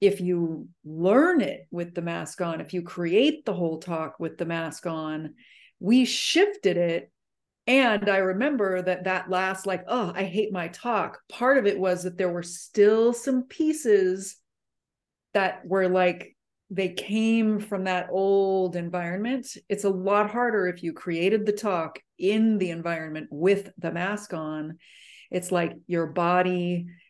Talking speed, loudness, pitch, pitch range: 160 wpm, -25 LUFS, 185 Hz, 175-210 Hz